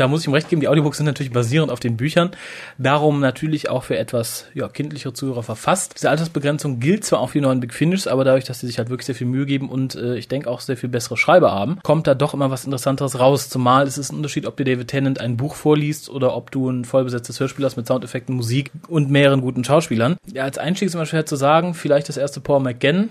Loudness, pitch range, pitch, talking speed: -20 LUFS, 130-150 Hz, 135 Hz, 260 wpm